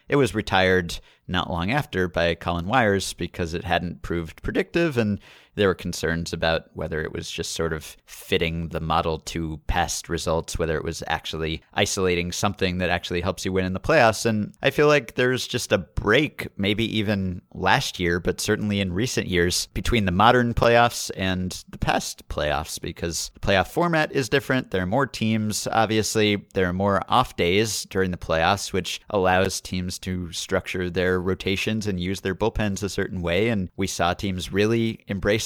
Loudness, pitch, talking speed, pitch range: -24 LUFS, 95 Hz, 185 wpm, 85-110 Hz